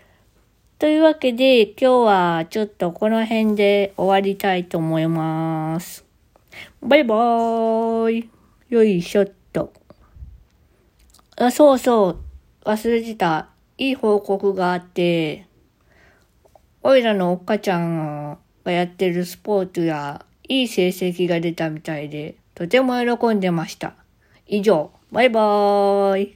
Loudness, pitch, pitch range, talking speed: -19 LUFS, 200 Hz, 175-225 Hz, 230 characters per minute